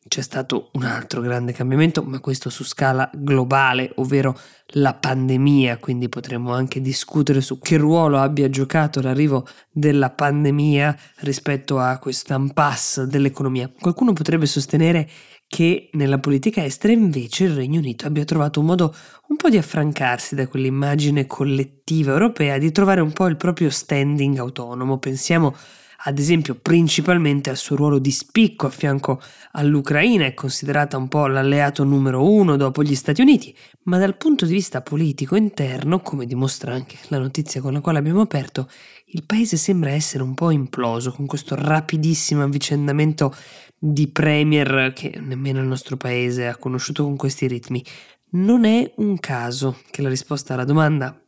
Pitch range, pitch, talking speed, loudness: 135-155 Hz, 145 Hz, 155 wpm, -19 LUFS